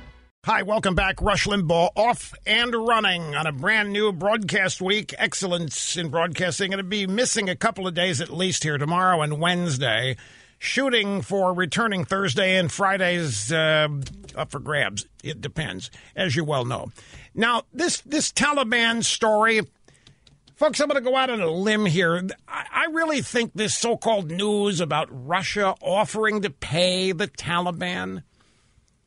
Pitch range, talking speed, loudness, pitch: 170-220 Hz, 155 wpm, -23 LUFS, 190 Hz